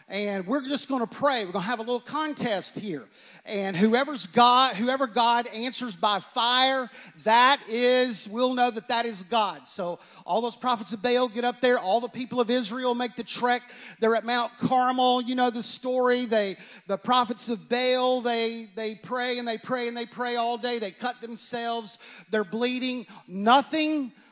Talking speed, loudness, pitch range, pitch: 185 wpm, -25 LUFS, 225-250 Hz, 240 Hz